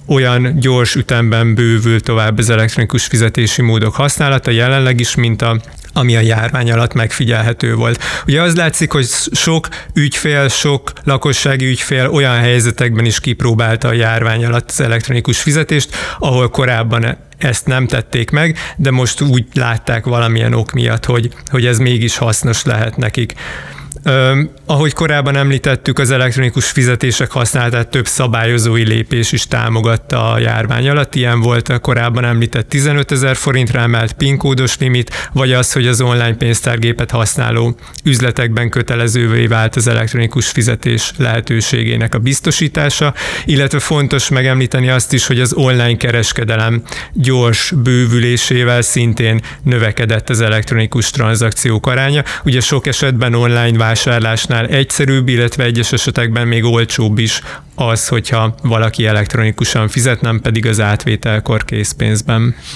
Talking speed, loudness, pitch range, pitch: 135 wpm, -12 LUFS, 115-135 Hz, 120 Hz